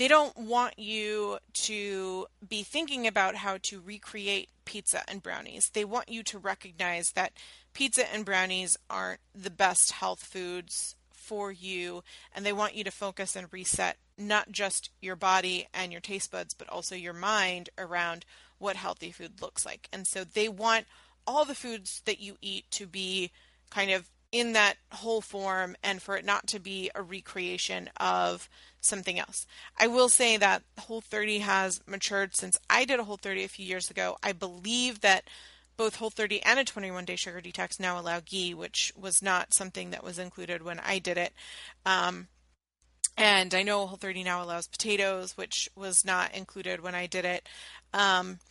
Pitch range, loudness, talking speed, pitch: 180-210 Hz, -29 LUFS, 180 wpm, 195 Hz